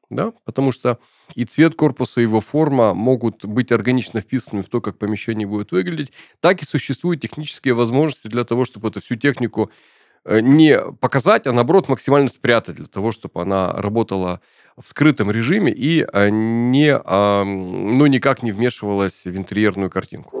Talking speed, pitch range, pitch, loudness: 155 wpm, 105-135 Hz, 115 Hz, -18 LUFS